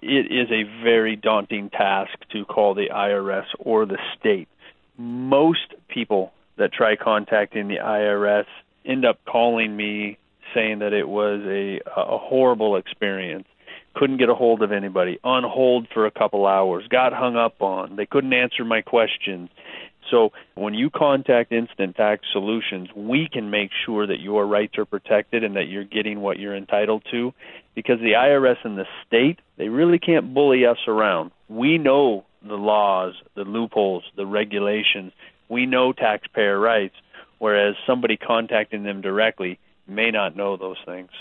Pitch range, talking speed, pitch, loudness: 100-120 Hz, 160 wpm, 105 Hz, -21 LUFS